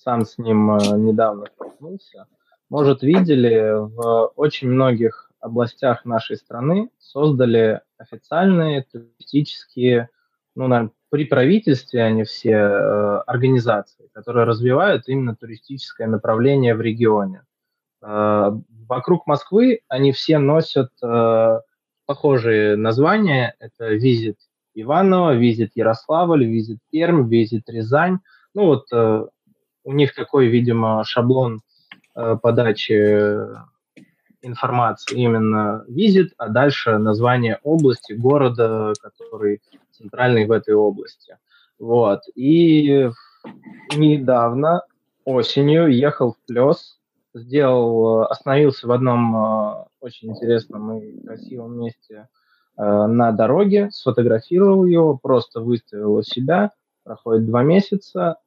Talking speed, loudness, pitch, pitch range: 105 wpm, -18 LUFS, 120 Hz, 110-145 Hz